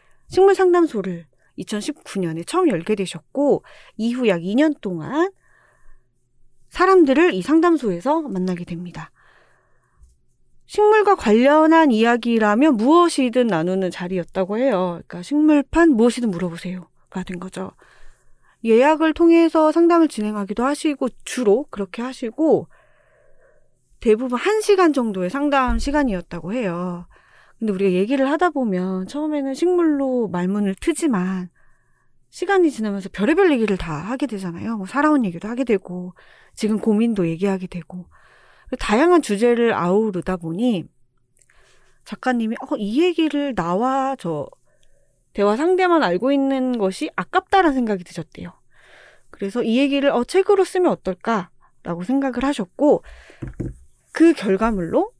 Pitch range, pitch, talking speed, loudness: 185-300 Hz, 230 Hz, 290 characters per minute, -19 LUFS